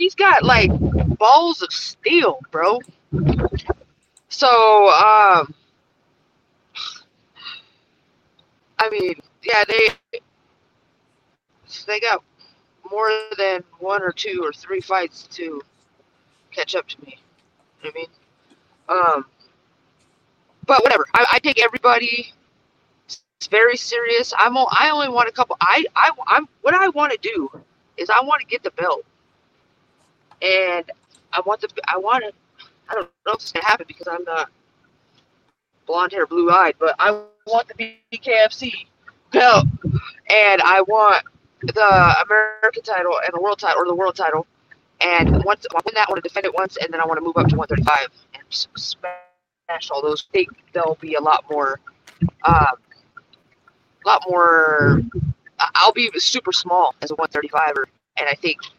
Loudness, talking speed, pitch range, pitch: -17 LUFS, 155 wpm, 170-260 Hz, 210 Hz